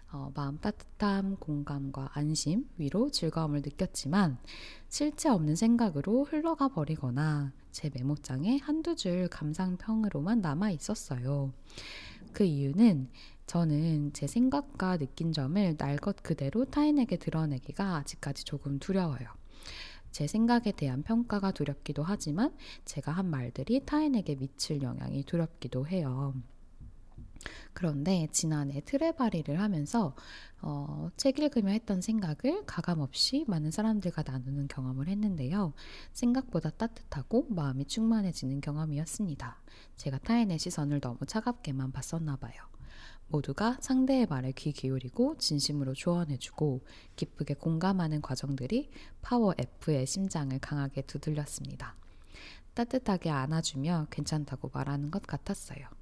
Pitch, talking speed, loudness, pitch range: 160 Hz, 305 characters per minute, -32 LUFS, 140-210 Hz